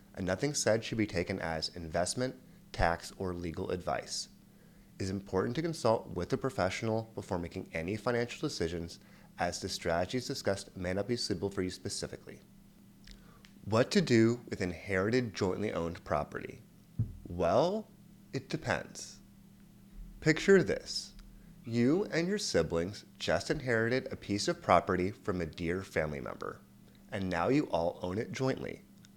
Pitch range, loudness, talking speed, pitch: 90-125 Hz, -33 LUFS, 145 wpm, 100 Hz